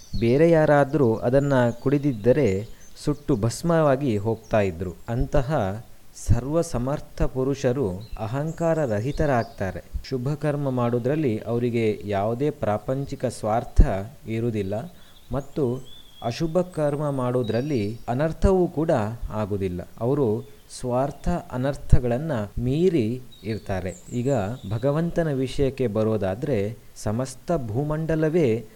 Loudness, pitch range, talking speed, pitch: -24 LUFS, 110-145 Hz, 85 wpm, 125 Hz